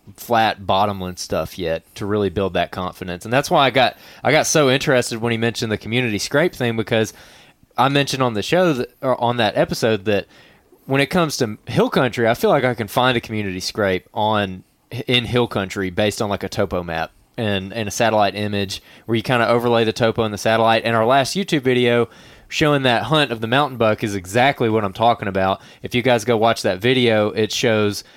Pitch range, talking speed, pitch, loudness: 100-125 Hz, 220 wpm, 115 Hz, -19 LUFS